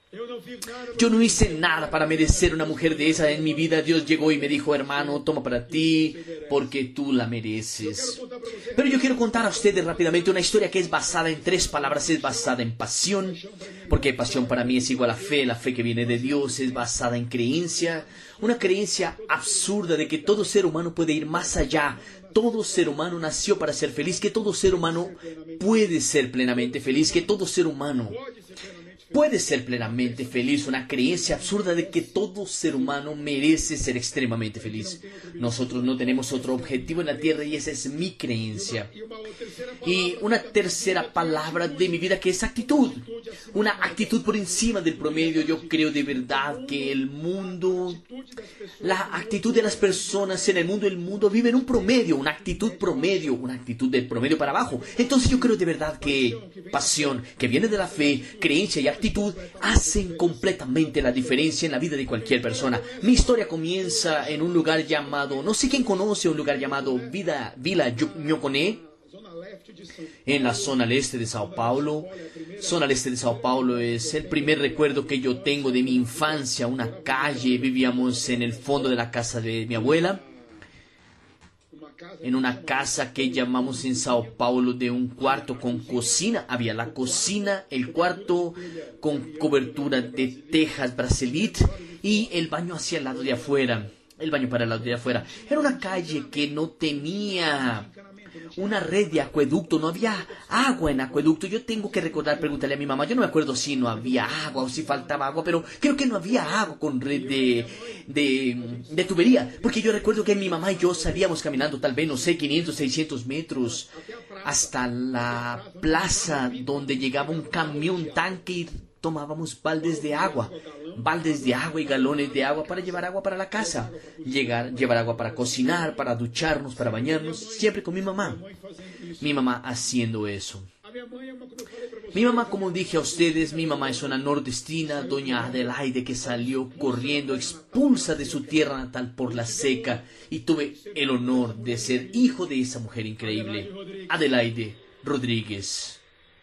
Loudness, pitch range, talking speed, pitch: -25 LUFS, 130-185 Hz, 175 wpm, 155 Hz